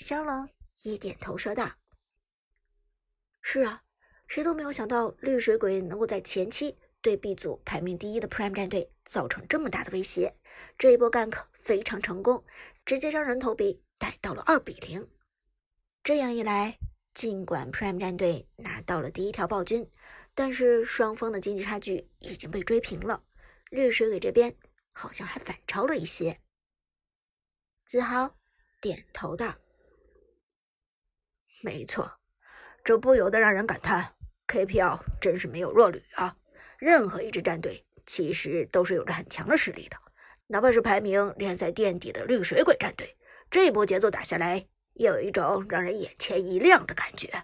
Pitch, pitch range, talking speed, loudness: 230 Hz, 195-305 Hz, 250 characters per minute, -26 LUFS